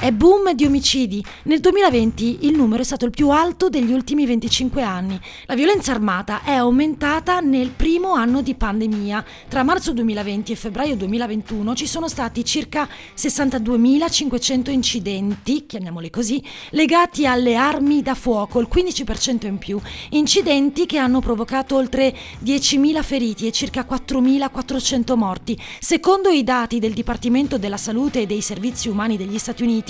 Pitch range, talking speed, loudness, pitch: 230-285 Hz, 150 wpm, -18 LUFS, 255 Hz